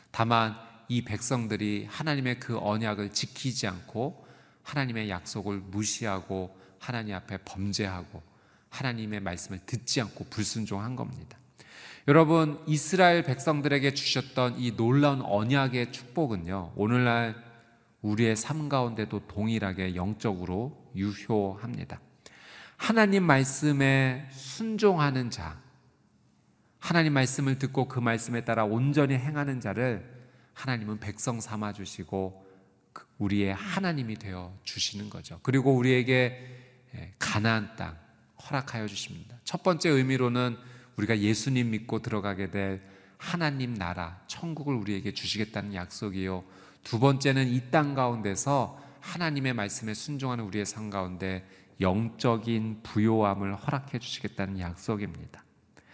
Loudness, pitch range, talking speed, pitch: -29 LUFS, 100-135 Hz, 295 characters per minute, 115 Hz